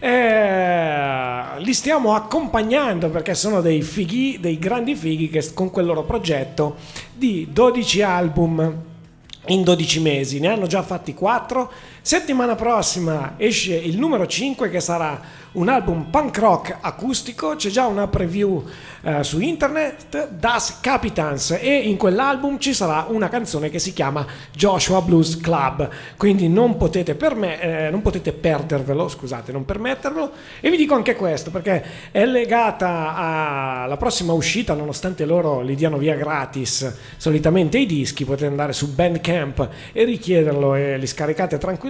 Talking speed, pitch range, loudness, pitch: 150 wpm, 155-225 Hz, -20 LUFS, 175 Hz